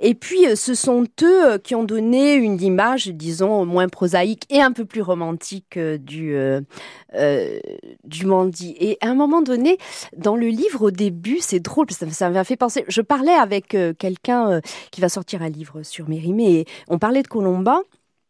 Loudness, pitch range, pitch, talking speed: -19 LUFS, 180-255 Hz, 205 Hz, 185 wpm